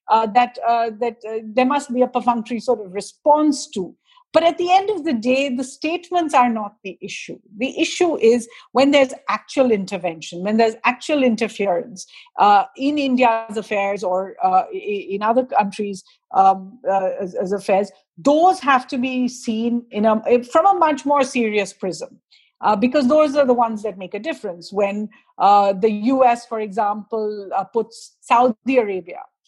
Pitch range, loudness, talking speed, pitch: 210-280 Hz, -19 LUFS, 175 wpm, 235 Hz